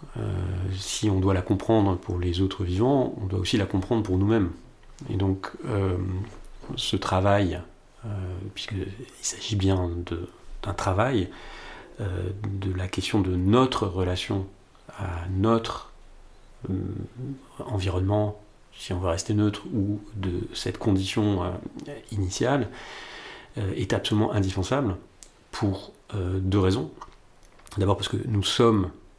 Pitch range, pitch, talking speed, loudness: 95-105 Hz, 100 Hz, 130 wpm, -27 LUFS